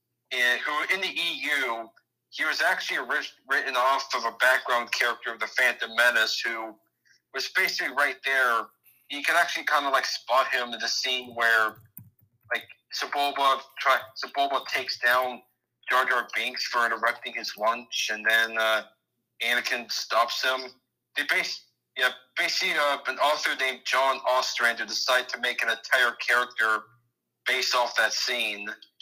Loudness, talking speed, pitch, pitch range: -25 LUFS, 155 wpm, 120 Hz, 115-130 Hz